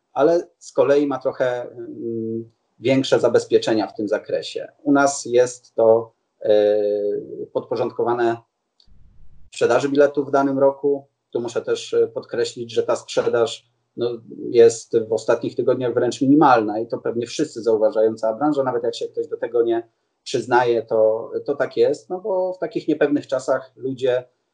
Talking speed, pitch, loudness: 140 wpm, 145 Hz, -20 LUFS